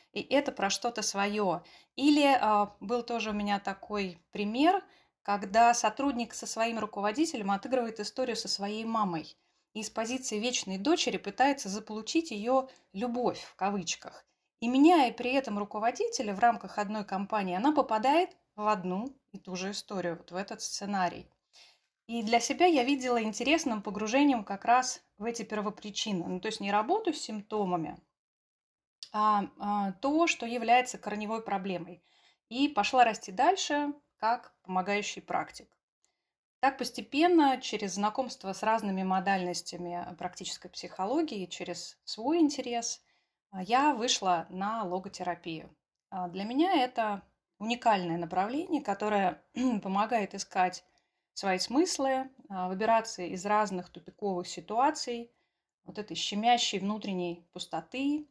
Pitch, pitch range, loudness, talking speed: 215 Hz, 195-255 Hz, -31 LUFS, 125 wpm